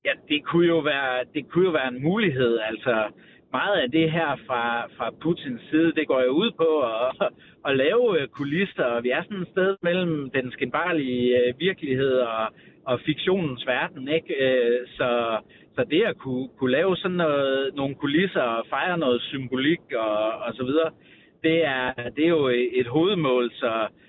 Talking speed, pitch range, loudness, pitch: 170 wpm, 125-165 Hz, -24 LUFS, 140 Hz